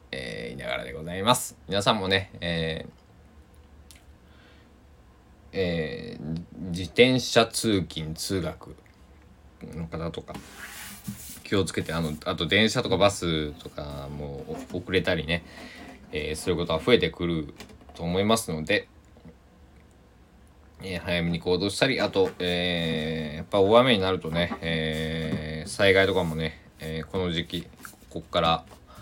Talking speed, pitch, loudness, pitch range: 245 characters per minute, 80 Hz, -26 LUFS, 80-90 Hz